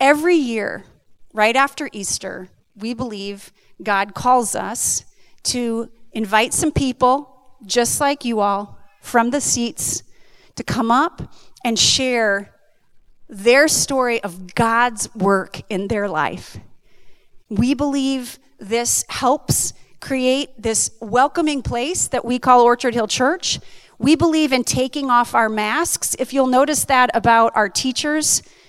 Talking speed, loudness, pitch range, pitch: 130 wpm, -18 LUFS, 220-270 Hz, 245 Hz